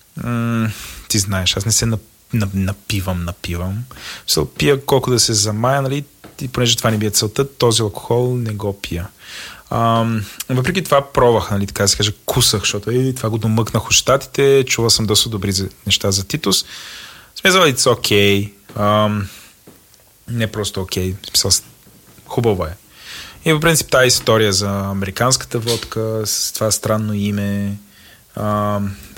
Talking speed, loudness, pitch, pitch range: 155 wpm, -16 LUFS, 110 Hz, 100-120 Hz